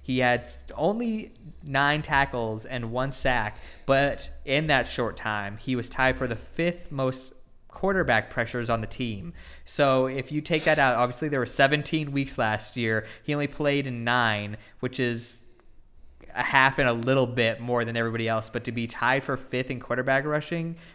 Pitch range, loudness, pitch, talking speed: 115-140 Hz, -26 LUFS, 125 Hz, 185 wpm